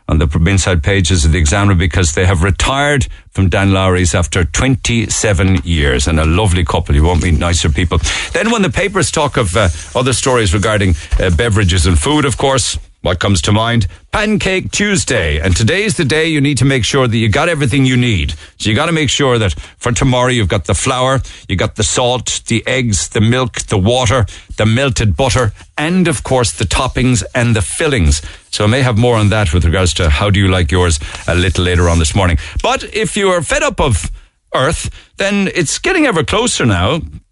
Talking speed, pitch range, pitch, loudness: 210 wpm, 90-130 Hz, 105 Hz, -13 LUFS